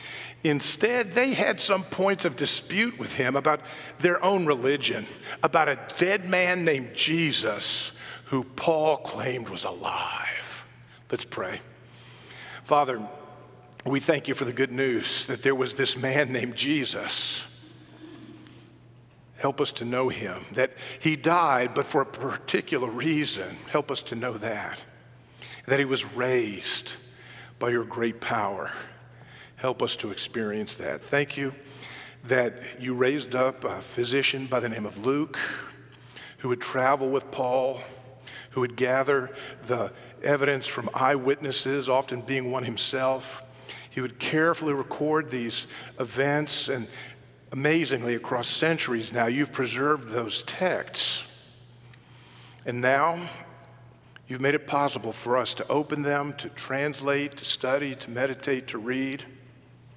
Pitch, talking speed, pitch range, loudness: 135 Hz, 135 wpm, 125-145 Hz, -27 LUFS